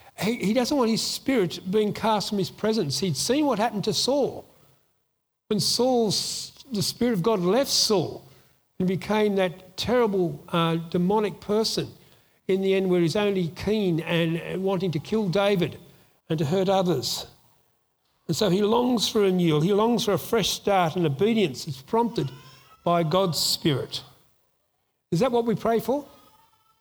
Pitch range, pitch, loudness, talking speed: 175-220 Hz, 195 Hz, -24 LUFS, 170 wpm